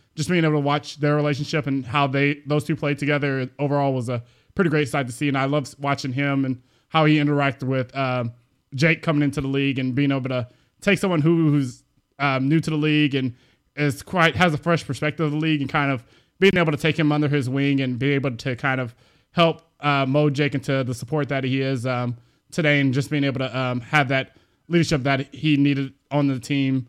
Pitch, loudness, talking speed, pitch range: 140 Hz, -22 LUFS, 235 wpm, 135-150 Hz